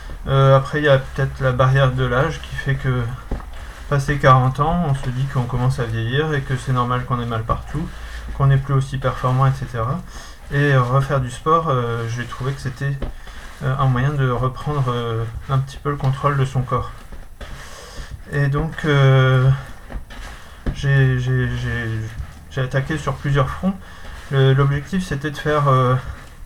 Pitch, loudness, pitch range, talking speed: 130 Hz, -19 LUFS, 120-140 Hz, 175 wpm